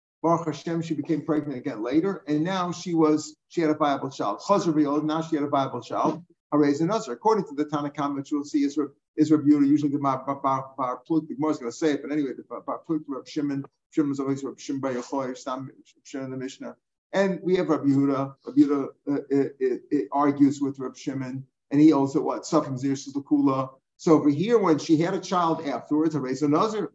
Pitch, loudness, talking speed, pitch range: 150 Hz, -25 LUFS, 225 wpm, 140-160 Hz